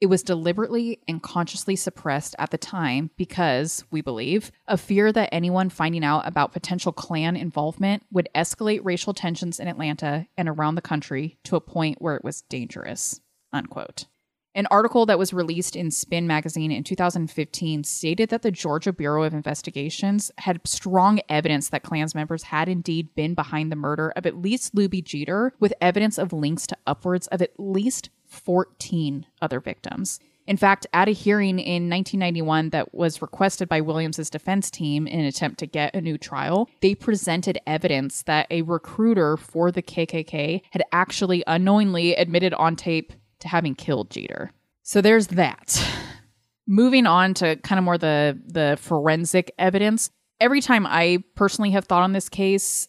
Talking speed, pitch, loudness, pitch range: 170 wpm, 175 Hz, -23 LUFS, 155-190 Hz